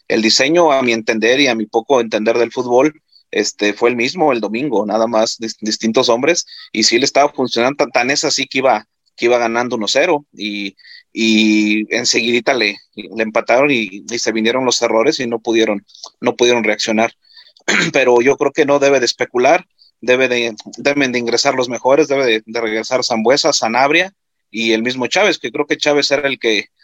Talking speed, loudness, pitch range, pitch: 205 wpm, -15 LUFS, 110-130 Hz, 120 Hz